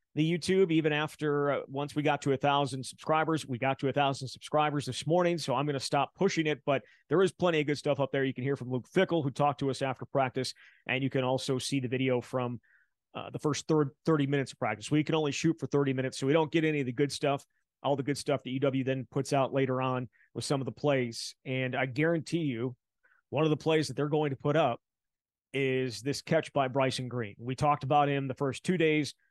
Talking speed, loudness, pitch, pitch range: 255 wpm, -30 LUFS, 140 Hz, 130-150 Hz